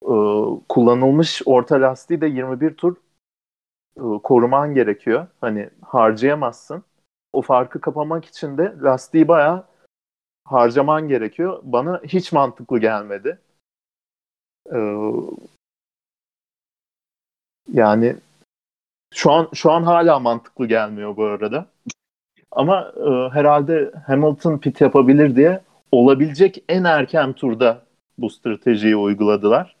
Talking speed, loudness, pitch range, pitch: 95 wpm, -17 LUFS, 110-155 Hz, 135 Hz